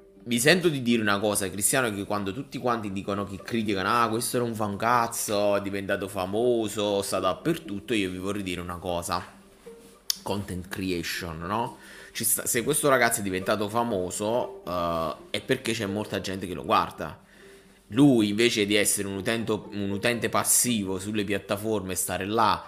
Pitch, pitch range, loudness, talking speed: 105 Hz, 100-115 Hz, -26 LUFS, 165 wpm